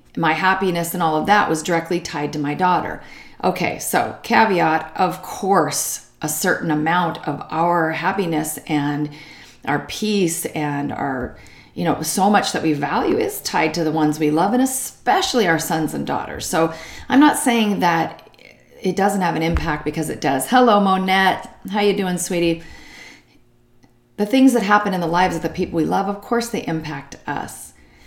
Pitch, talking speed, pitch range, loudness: 175 Hz, 180 wpm, 155-205 Hz, -19 LUFS